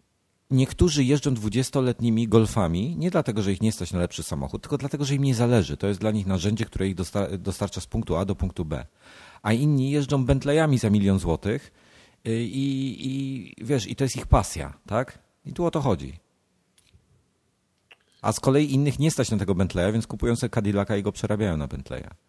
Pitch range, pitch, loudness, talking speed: 95-135 Hz, 110 Hz, -25 LUFS, 195 wpm